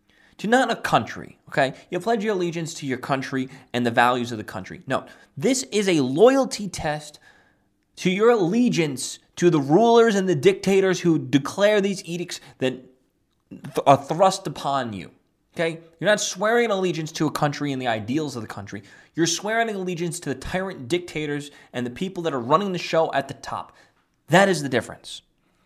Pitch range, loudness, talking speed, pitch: 135-195 Hz, -22 LUFS, 185 wpm, 165 Hz